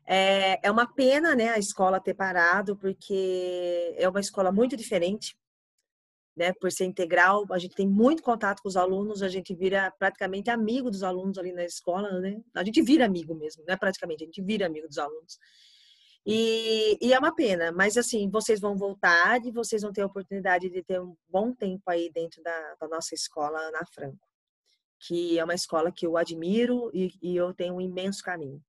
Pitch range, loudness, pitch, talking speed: 175-215 Hz, -27 LUFS, 190 Hz, 195 wpm